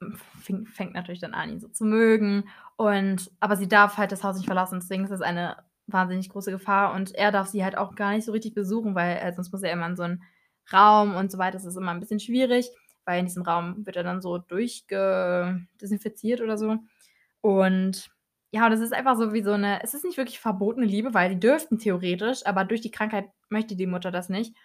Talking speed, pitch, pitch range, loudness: 230 wpm, 200 Hz, 185-220 Hz, -25 LUFS